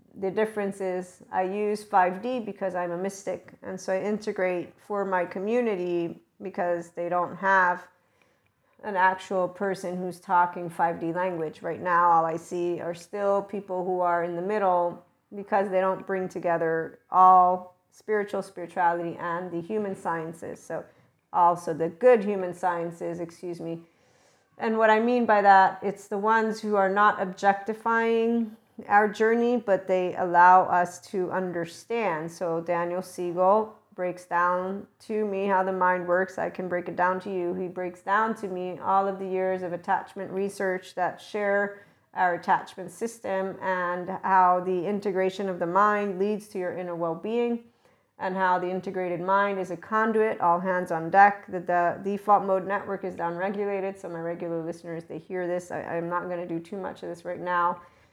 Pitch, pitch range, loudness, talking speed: 185 Hz, 175-200 Hz, -26 LUFS, 175 wpm